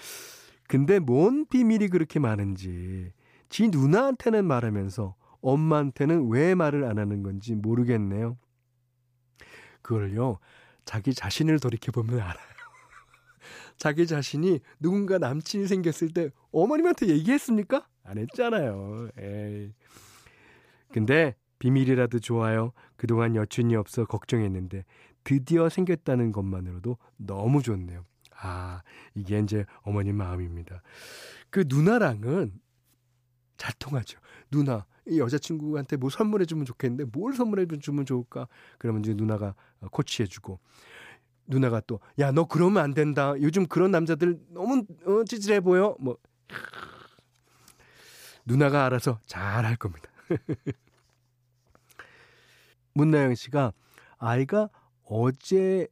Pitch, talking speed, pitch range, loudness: 130 Hz, 260 characters per minute, 110-165 Hz, -26 LUFS